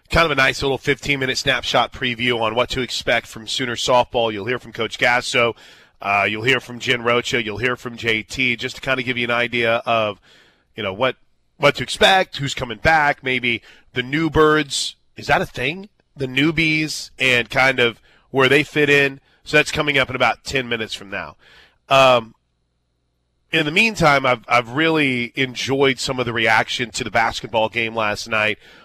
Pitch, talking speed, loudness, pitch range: 125 Hz, 195 wpm, -18 LUFS, 115-140 Hz